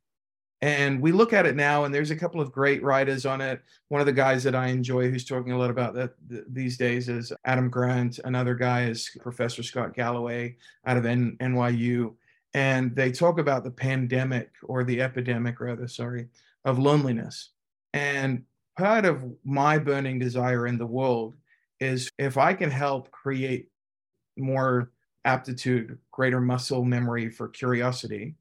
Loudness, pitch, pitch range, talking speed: -26 LUFS, 125 Hz, 120-135 Hz, 165 wpm